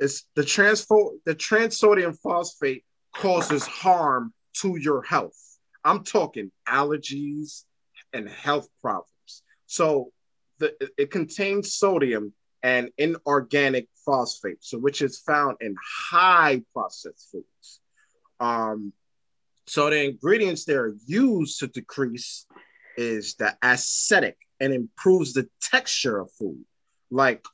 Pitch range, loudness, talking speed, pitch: 125-185 Hz, -23 LUFS, 115 wpm, 145 Hz